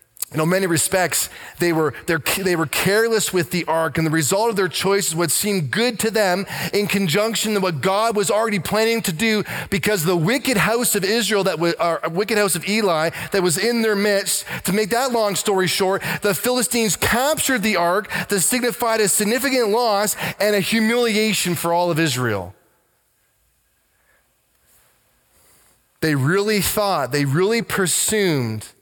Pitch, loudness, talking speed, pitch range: 195 Hz, -19 LUFS, 160 wpm, 170-215 Hz